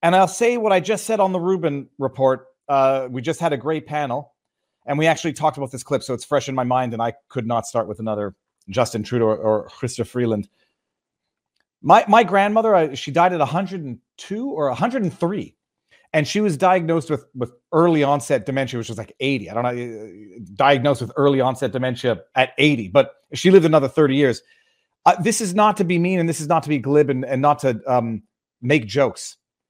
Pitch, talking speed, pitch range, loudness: 145 Hz, 210 wpm, 125-170 Hz, -20 LUFS